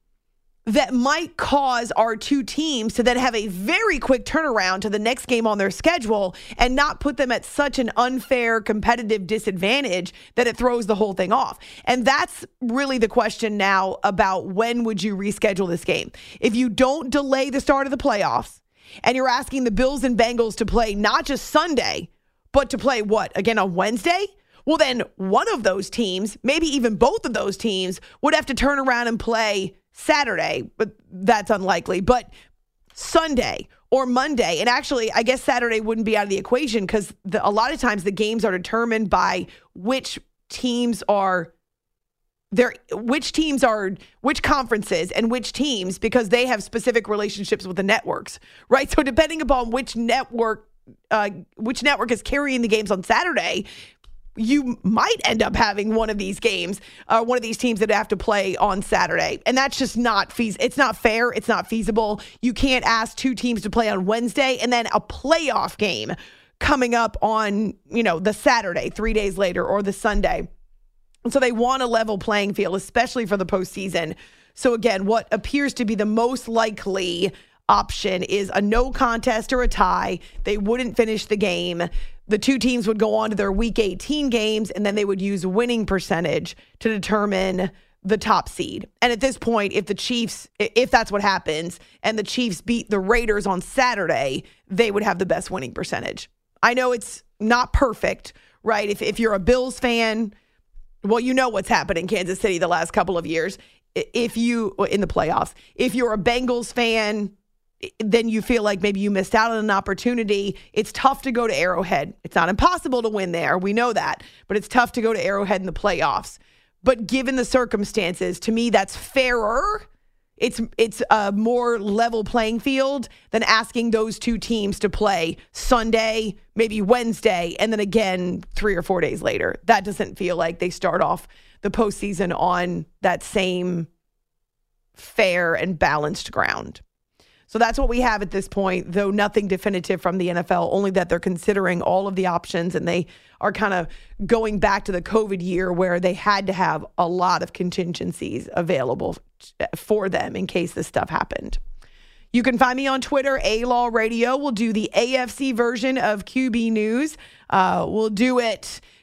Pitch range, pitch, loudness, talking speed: 200-245 Hz, 225 Hz, -21 LUFS, 185 wpm